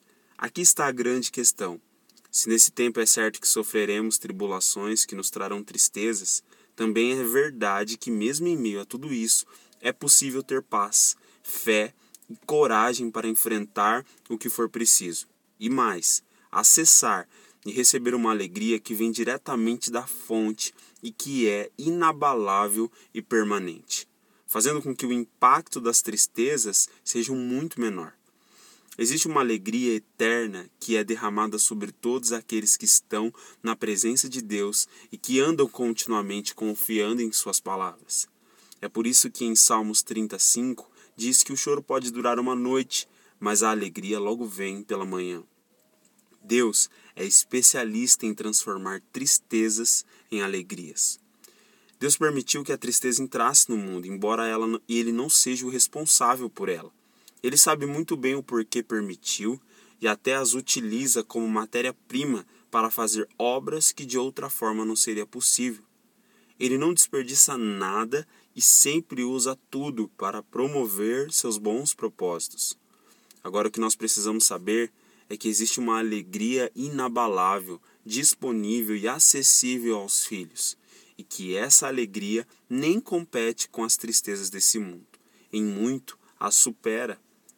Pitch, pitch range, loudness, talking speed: 115 Hz, 110-130 Hz, -23 LUFS, 140 wpm